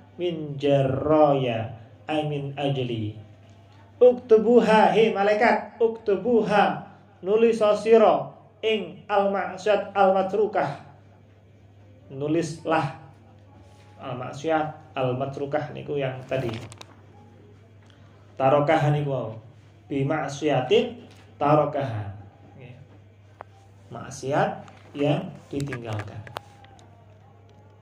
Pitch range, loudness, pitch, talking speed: 105-165 Hz, -23 LUFS, 135 Hz, 65 wpm